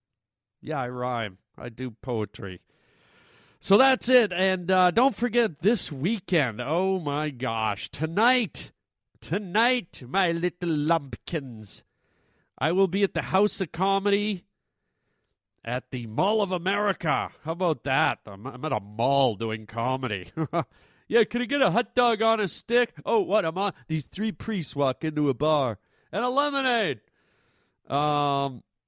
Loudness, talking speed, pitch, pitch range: -26 LUFS, 150 wpm, 160 Hz, 125-205 Hz